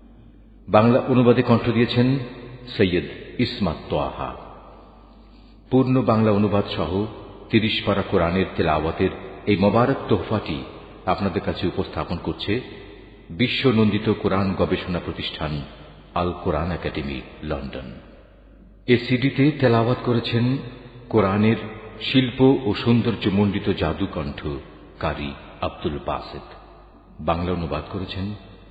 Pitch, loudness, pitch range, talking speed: 100 Hz, -22 LUFS, 85-115 Hz, 100 wpm